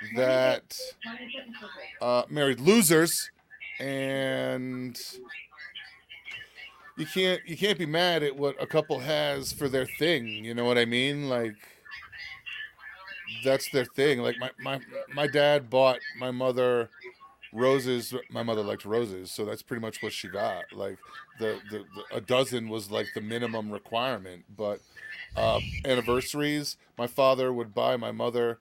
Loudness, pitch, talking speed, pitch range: -28 LUFS, 130 Hz, 145 wpm, 120-150 Hz